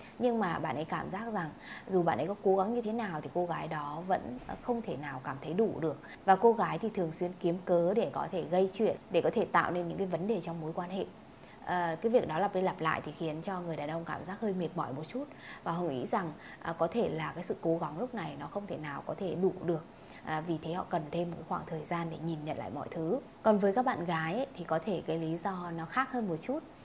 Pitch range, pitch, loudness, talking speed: 160-200 Hz, 175 Hz, -34 LUFS, 290 wpm